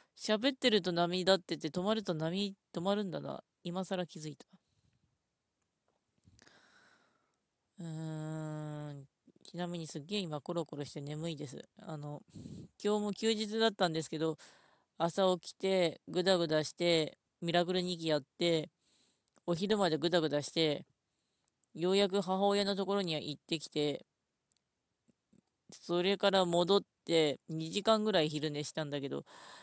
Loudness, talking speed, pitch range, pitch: -34 LUFS, 260 characters per minute, 155-195 Hz, 175 Hz